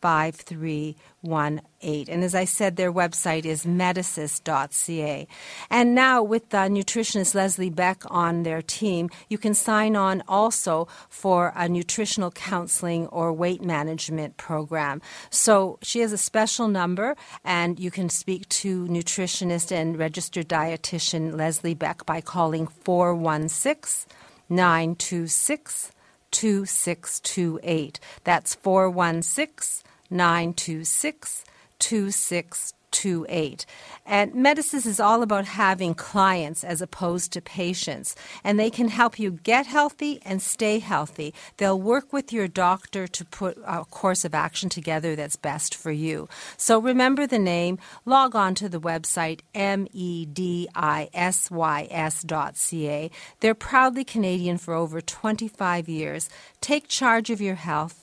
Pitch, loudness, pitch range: 180 Hz, -24 LUFS, 165-205 Hz